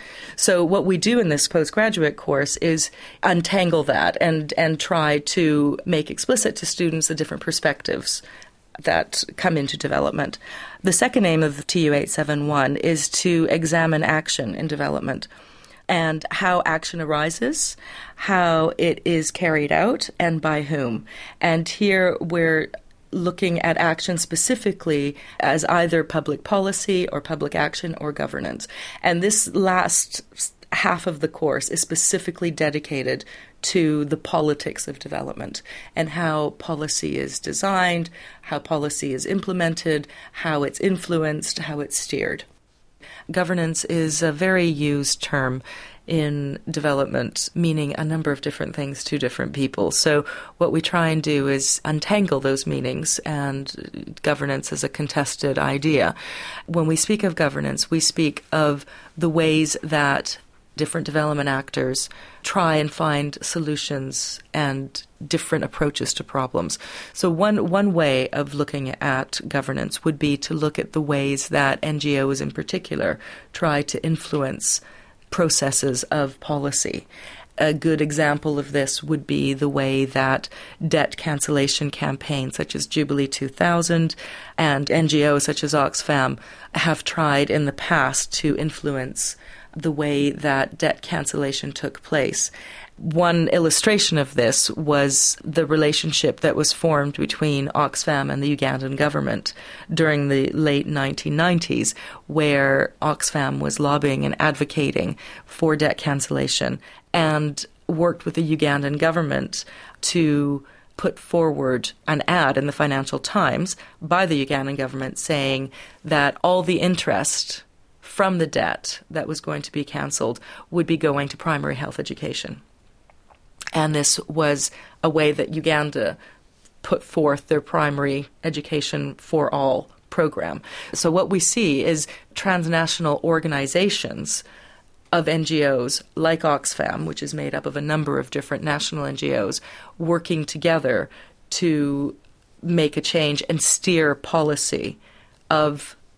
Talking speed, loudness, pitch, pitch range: 135 wpm, -22 LUFS, 155 Hz, 145-165 Hz